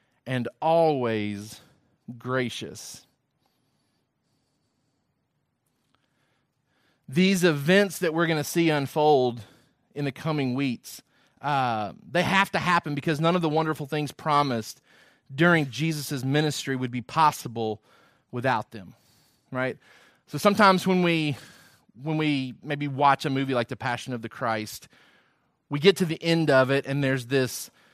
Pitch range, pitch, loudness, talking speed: 130-160 Hz, 145 Hz, -25 LUFS, 135 wpm